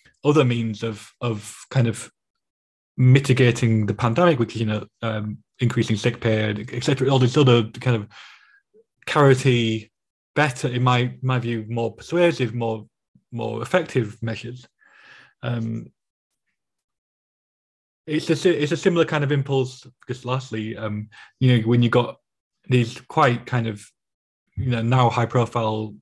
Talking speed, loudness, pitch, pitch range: 140 wpm, -21 LUFS, 120 Hz, 115-130 Hz